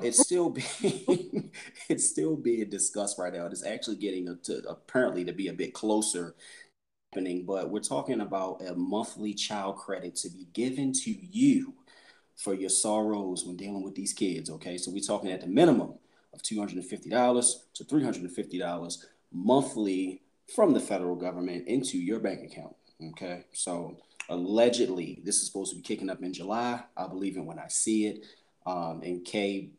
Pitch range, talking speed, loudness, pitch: 90-110 Hz, 185 wpm, -30 LUFS, 95 Hz